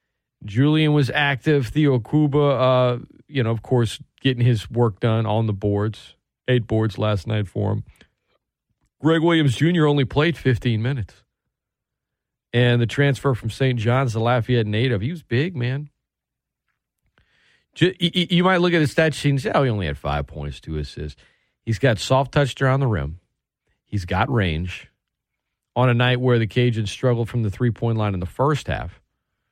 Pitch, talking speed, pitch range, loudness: 125 Hz, 175 wpm, 110-140 Hz, -21 LUFS